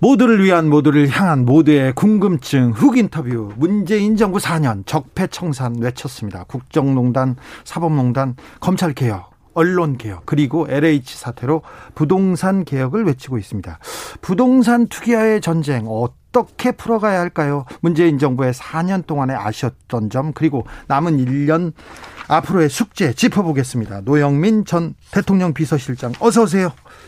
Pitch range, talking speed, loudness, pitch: 130-185 Hz, 310 characters per minute, -17 LUFS, 155 Hz